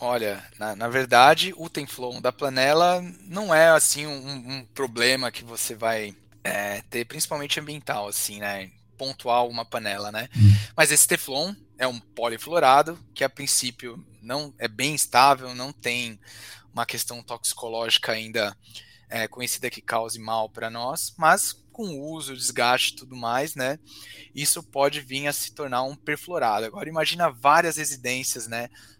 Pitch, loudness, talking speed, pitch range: 125 Hz, -24 LUFS, 155 wpm, 115-145 Hz